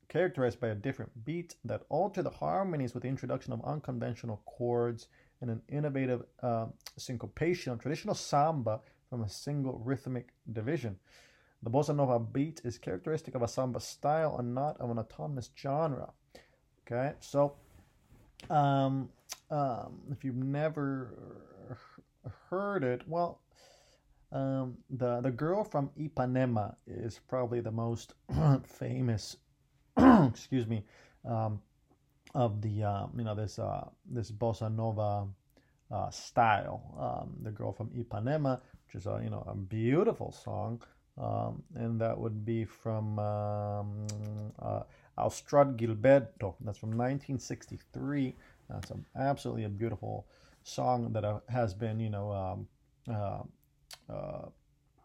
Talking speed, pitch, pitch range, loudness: 130 wpm, 125 Hz, 115-135 Hz, -34 LUFS